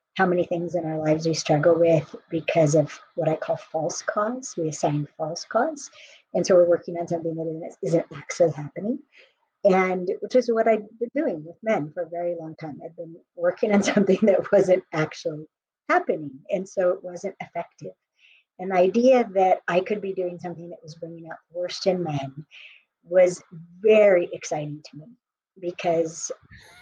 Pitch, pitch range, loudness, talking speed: 175 Hz, 165-200 Hz, -24 LUFS, 175 wpm